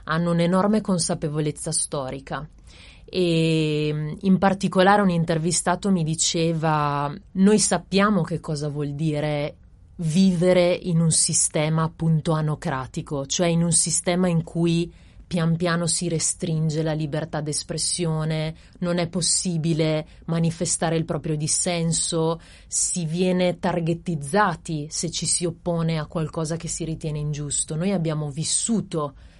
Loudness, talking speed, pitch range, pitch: -23 LUFS, 120 wpm, 155-175 Hz, 165 Hz